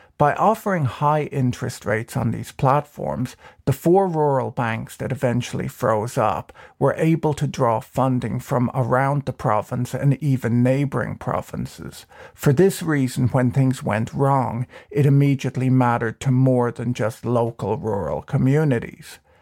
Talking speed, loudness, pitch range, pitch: 140 wpm, -21 LUFS, 120-140 Hz, 130 Hz